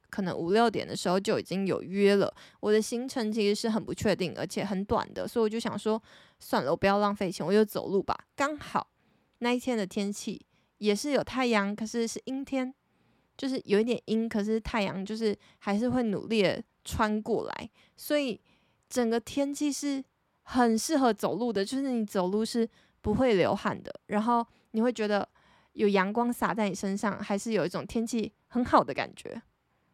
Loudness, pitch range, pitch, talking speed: -29 LUFS, 200-240 Hz, 220 Hz, 275 characters per minute